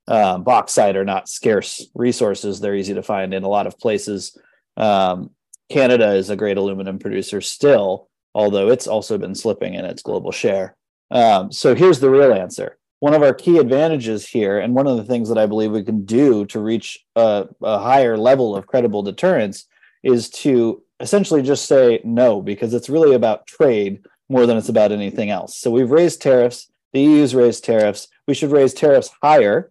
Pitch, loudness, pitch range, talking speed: 115 Hz, -17 LUFS, 100-135 Hz, 190 wpm